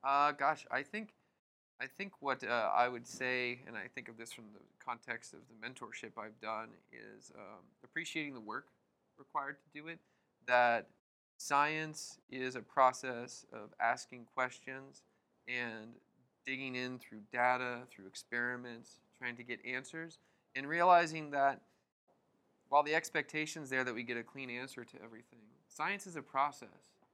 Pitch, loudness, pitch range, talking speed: 130 Hz, -37 LUFS, 120-145 Hz, 160 wpm